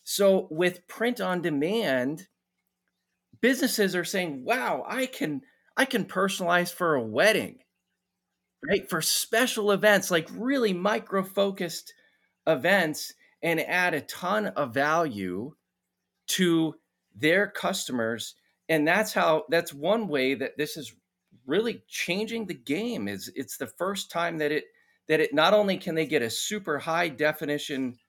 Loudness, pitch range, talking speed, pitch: -26 LUFS, 155-215 Hz, 140 wpm, 180 Hz